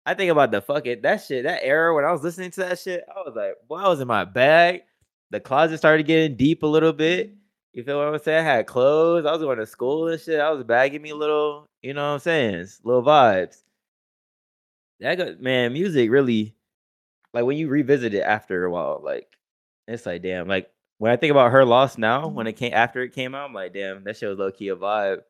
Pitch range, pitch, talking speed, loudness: 115-160 Hz, 140 Hz, 245 wpm, -21 LUFS